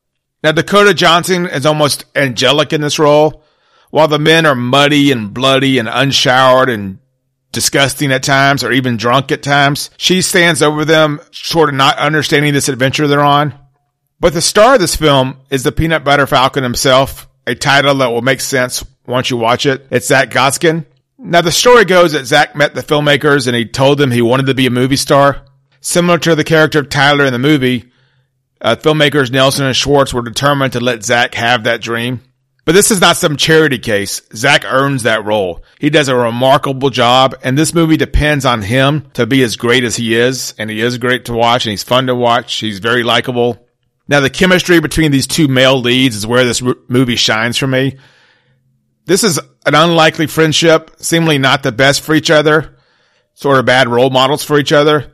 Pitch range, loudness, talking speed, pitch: 125-150 Hz, -11 LUFS, 200 wpm, 135 Hz